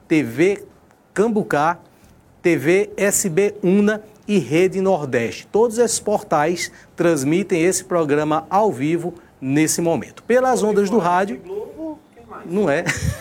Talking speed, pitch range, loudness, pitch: 110 wpm, 165-210 Hz, -19 LUFS, 190 Hz